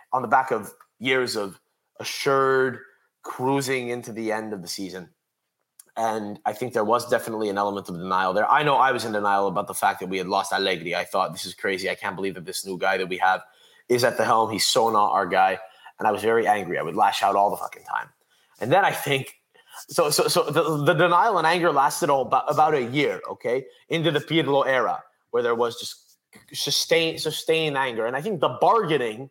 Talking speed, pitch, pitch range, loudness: 225 wpm, 115 Hz, 95-150 Hz, -23 LUFS